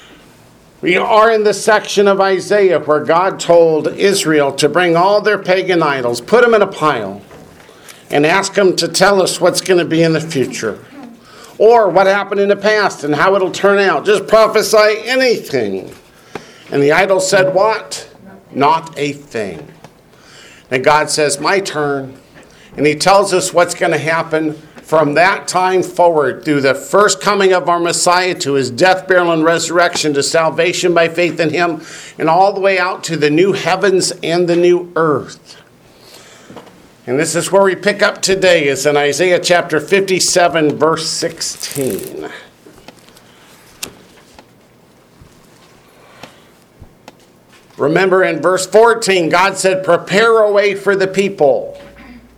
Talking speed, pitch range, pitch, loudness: 150 wpm, 160-195 Hz, 180 Hz, -13 LUFS